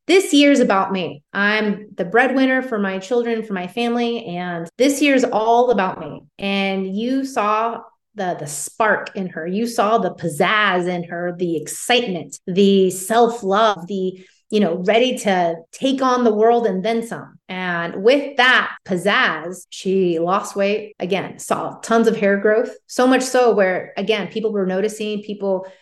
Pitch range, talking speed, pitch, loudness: 185-235 Hz, 165 wpm, 205 Hz, -18 LUFS